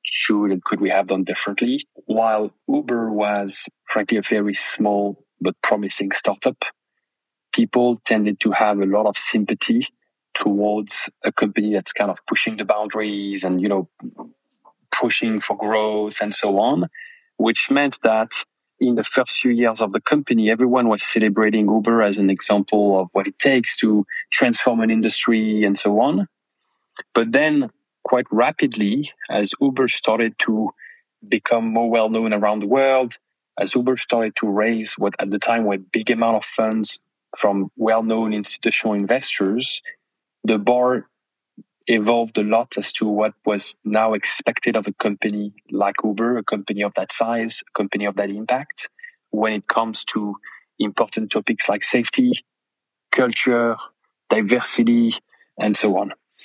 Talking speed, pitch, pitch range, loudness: 155 wpm, 110 Hz, 105-120 Hz, -20 LUFS